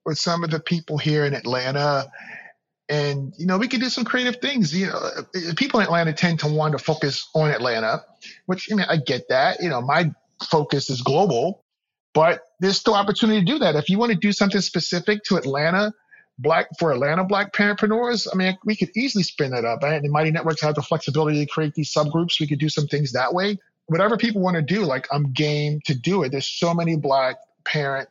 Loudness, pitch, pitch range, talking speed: -21 LUFS, 165 Hz, 150-200 Hz, 225 wpm